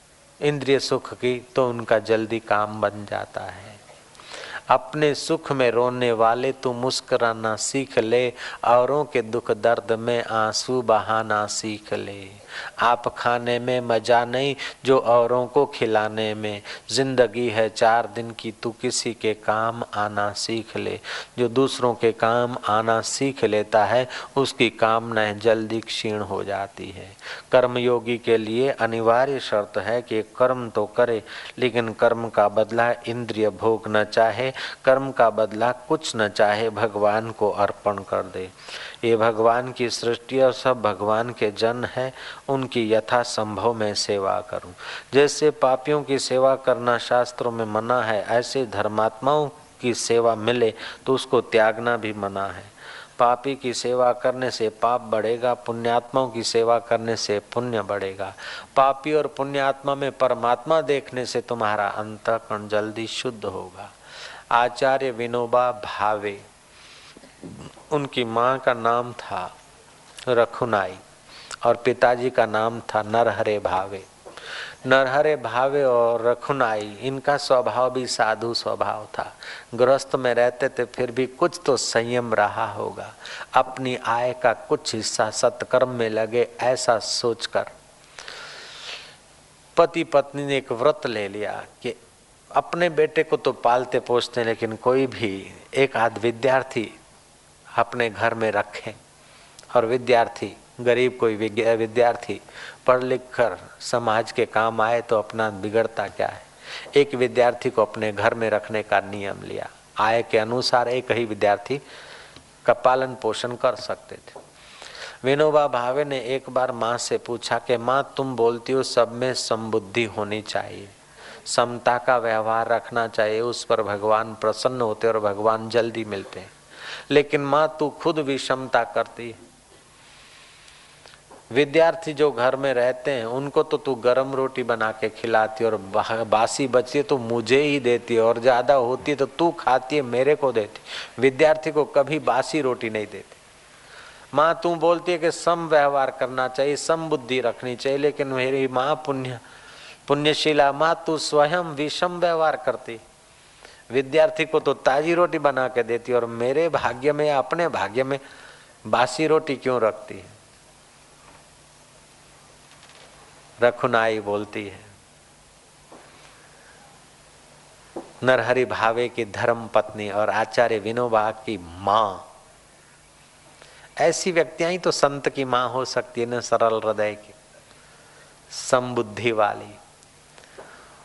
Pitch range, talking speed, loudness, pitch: 110-130 Hz, 140 wpm, -22 LUFS, 120 Hz